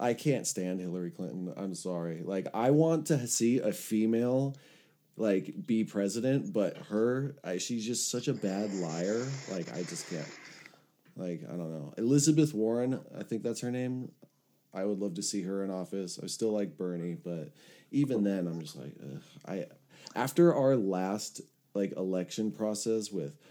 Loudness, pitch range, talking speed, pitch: -32 LUFS, 95-125 Hz, 175 wpm, 110 Hz